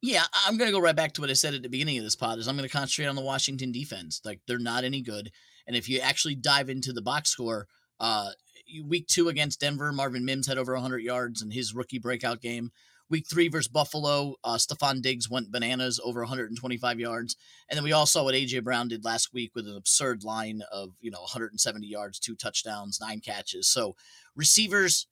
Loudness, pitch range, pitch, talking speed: -27 LUFS, 115-145 Hz, 130 Hz, 220 wpm